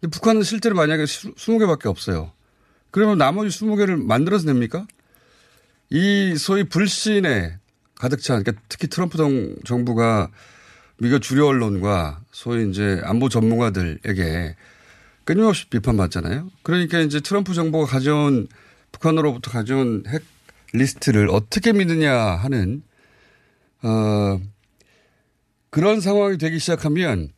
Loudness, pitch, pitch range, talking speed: -20 LUFS, 135 Hz, 105-170 Hz, 280 characters per minute